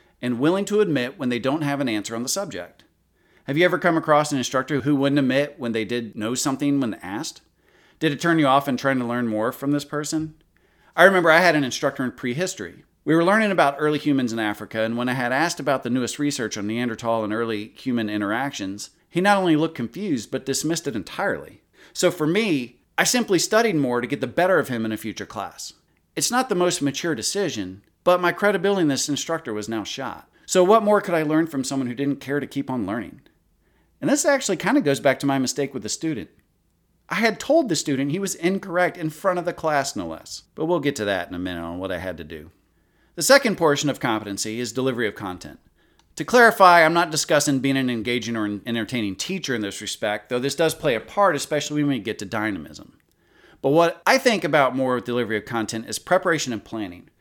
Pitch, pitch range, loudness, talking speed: 140 Hz, 120-170 Hz, -22 LUFS, 230 wpm